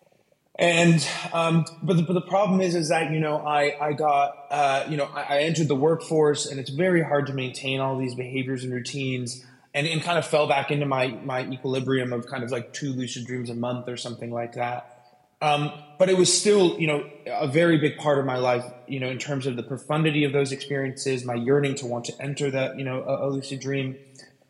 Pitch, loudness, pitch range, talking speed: 140 Hz, -25 LUFS, 130-150 Hz, 230 wpm